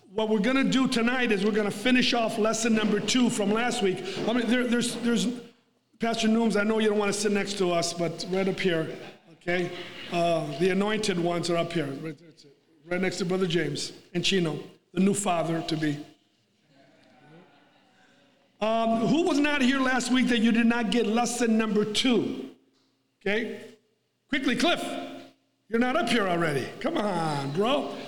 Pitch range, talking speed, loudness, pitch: 175-235 Hz, 180 wpm, -26 LUFS, 210 Hz